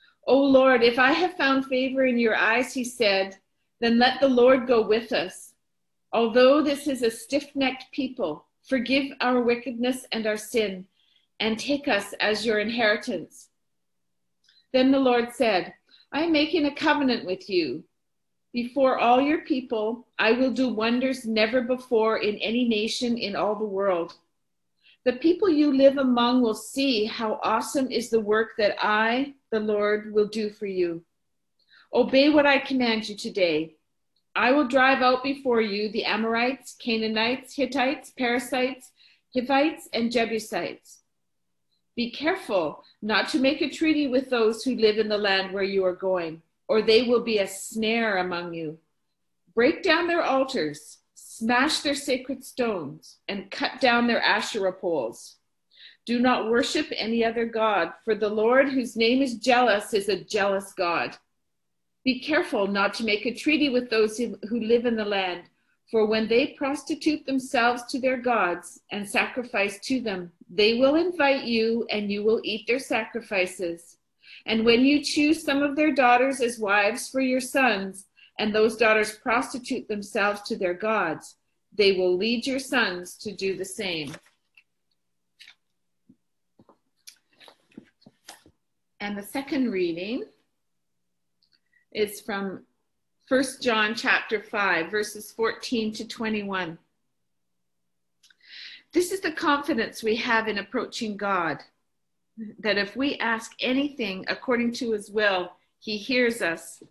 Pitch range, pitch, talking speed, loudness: 205-260 Hz, 230 Hz, 150 wpm, -24 LUFS